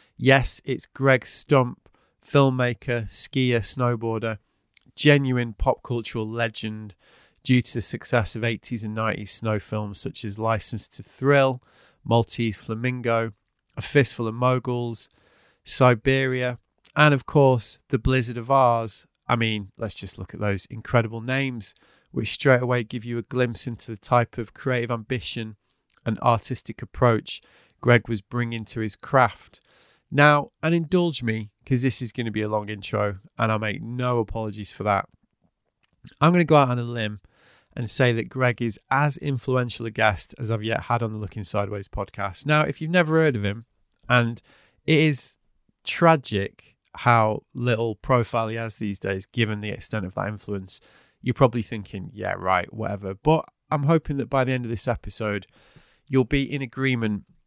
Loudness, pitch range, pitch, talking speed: -24 LUFS, 110-130 Hz, 120 Hz, 170 wpm